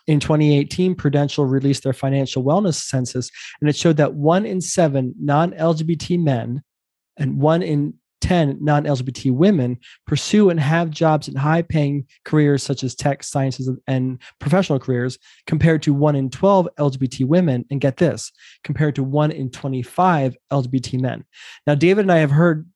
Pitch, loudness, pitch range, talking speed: 145 Hz, -19 LUFS, 135-160 Hz, 165 wpm